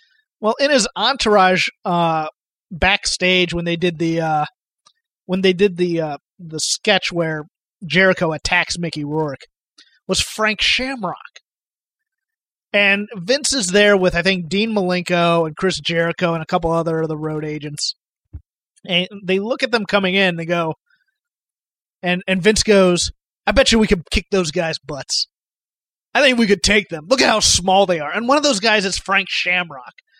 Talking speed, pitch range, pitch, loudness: 175 wpm, 170-215 Hz, 185 Hz, -17 LUFS